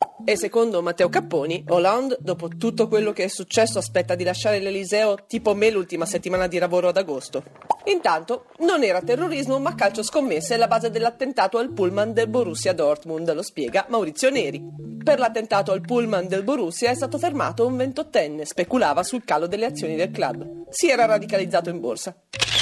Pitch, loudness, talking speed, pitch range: 210 Hz, -22 LUFS, 170 wpm, 180-245 Hz